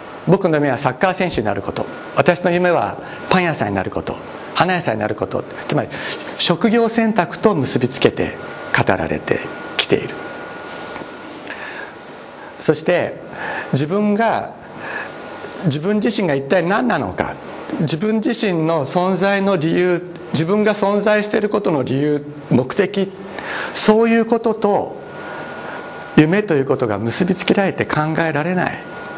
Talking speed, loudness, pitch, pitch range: 265 characters per minute, -18 LUFS, 180 Hz, 155-210 Hz